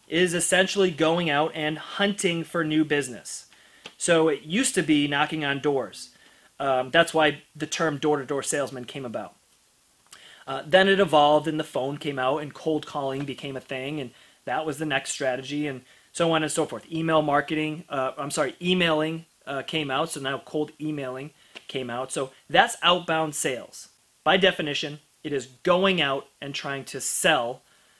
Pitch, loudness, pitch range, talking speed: 150 Hz, -25 LUFS, 140-160 Hz, 180 wpm